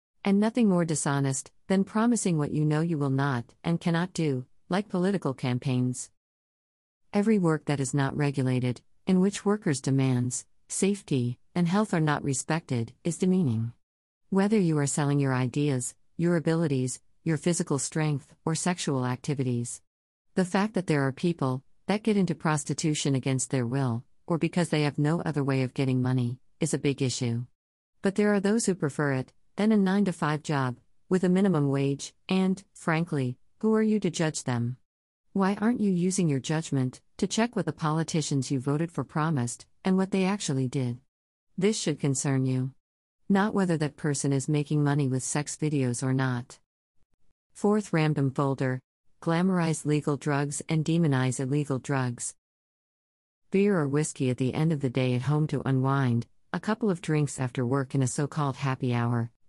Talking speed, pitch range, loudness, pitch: 175 wpm, 130-175 Hz, -28 LUFS, 145 Hz